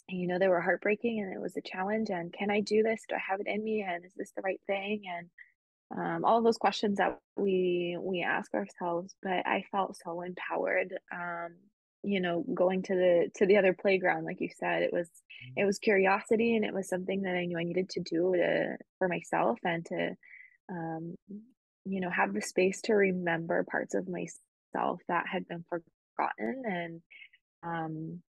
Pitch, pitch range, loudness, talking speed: 185 Hz, 175-205 Hz, -31 LUFS, 200 wpm